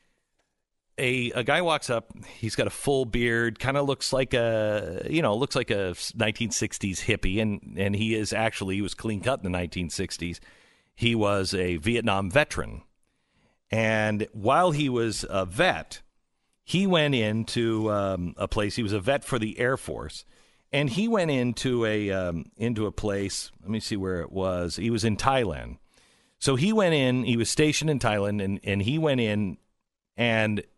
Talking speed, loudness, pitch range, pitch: 185 wpm, -26 LUFS, 100-125 Hz, 110 Hz